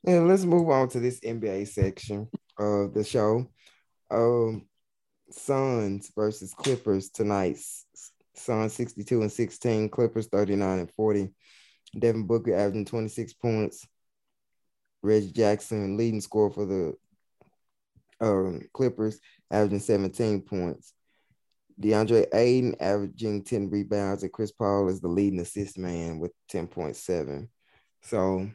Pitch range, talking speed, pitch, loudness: 100-115 Hz, 120 wpm, 105 Hz, -27 LUFS